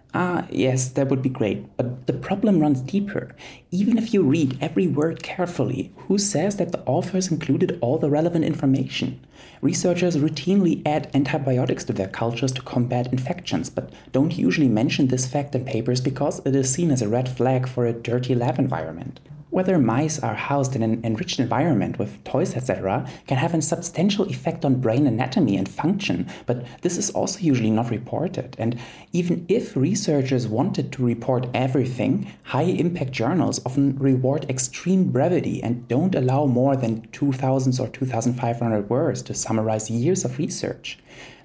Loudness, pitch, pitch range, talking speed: -23 LUFS, 135 Hz, 125-155 Hz, 170 wpm